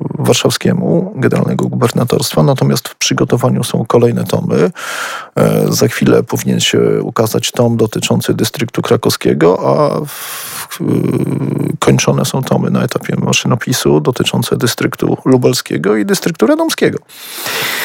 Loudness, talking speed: -13 LUFS, 105 wpm